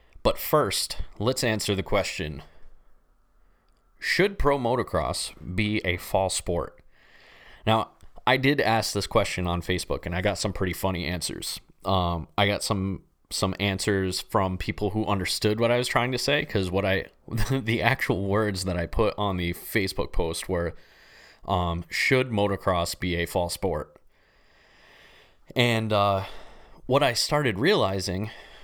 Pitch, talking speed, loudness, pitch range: 95 Hz, 150 wpm, -26 LUFS, 90-110 Hz